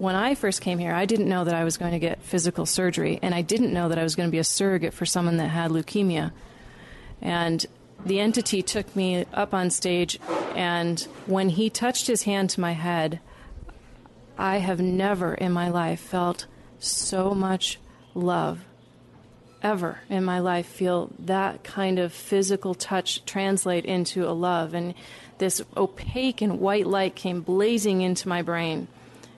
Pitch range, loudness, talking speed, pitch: 170-195 Hz, -25 LUFS, 175 wpm, 180 Hz